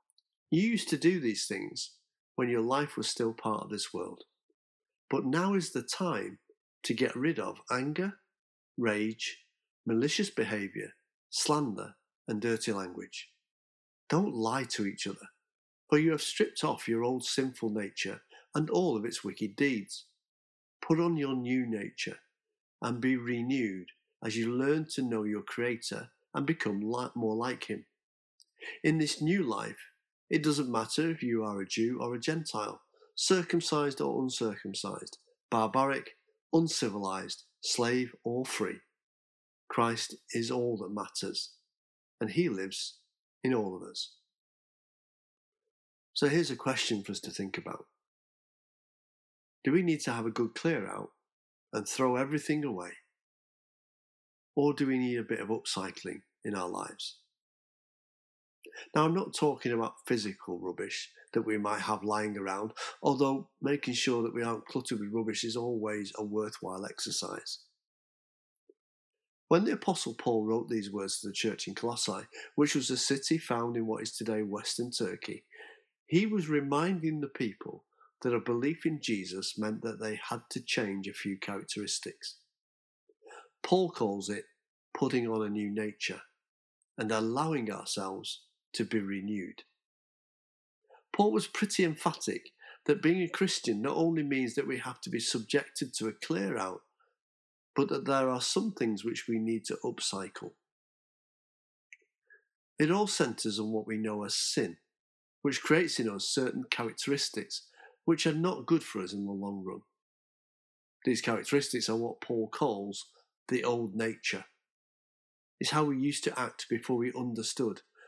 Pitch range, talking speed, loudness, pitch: 110-155 Hz, 150 wpm, -33 LUFS, 125 Hz